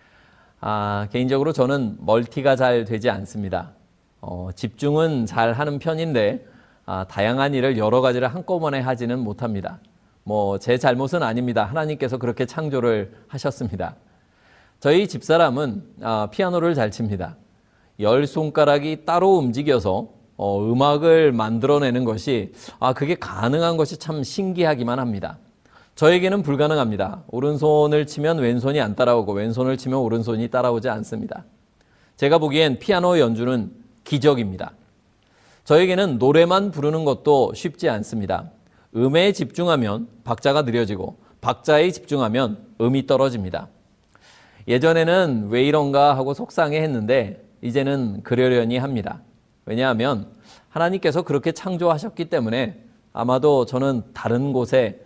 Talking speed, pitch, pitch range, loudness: 310 characters per minute, 130 Hz, 115-155 Hz, -21 LUFS